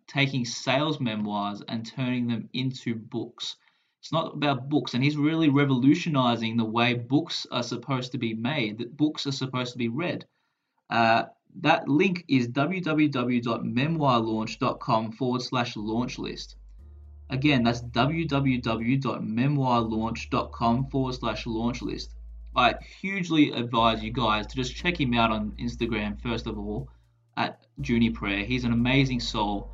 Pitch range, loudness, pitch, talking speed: 115-135 Hz, -26 LUFS, 120 Hz, 135 wpm